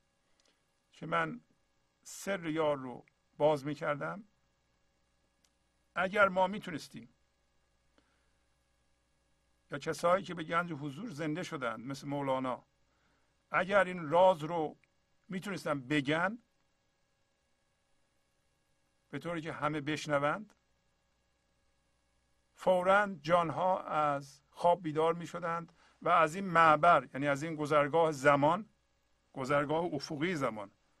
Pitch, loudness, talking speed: 150 Hz, -32 LUFS, 95 wpm